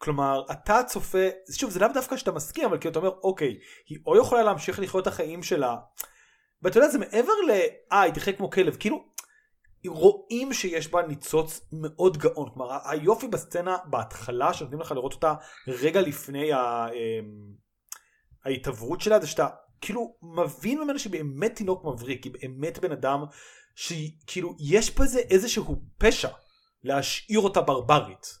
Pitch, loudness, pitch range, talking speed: 175 Hz, -26 LUFS, 145-215 Hz, 150 wpm